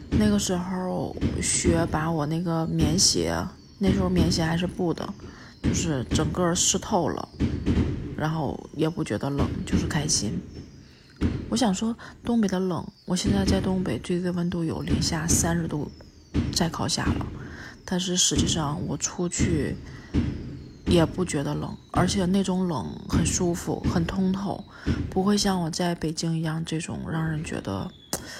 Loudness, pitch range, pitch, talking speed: -26 LUFS, 160-185 Hz, 170 Hz, 220 characters per minute